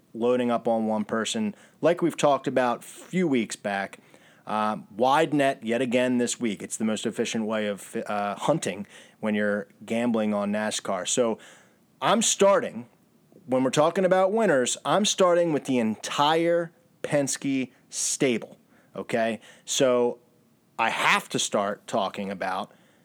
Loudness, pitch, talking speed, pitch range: -25 LUFS, 120 Hz, 145 wpm, 110-160 Hz